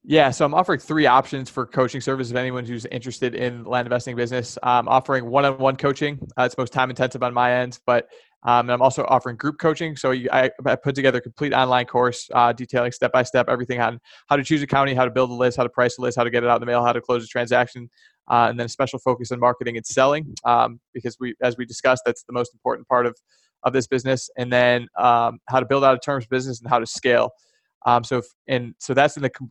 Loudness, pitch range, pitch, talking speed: -21 LUFS, 120-130 Hz, 125 Hz, 265 wpm